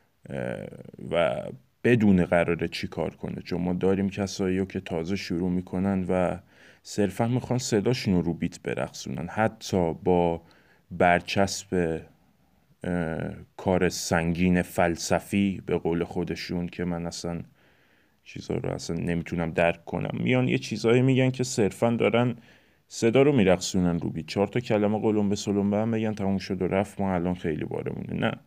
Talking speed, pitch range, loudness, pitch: 150 wpm, 85-105 Hz, -26 LUFS, 95 Hz